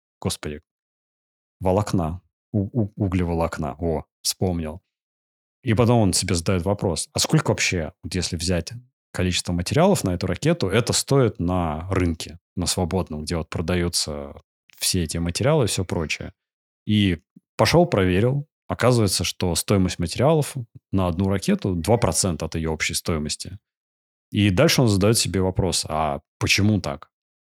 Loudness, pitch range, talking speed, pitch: -22 LUFS, 85-105 Hz, 135 wpm, 95 Hz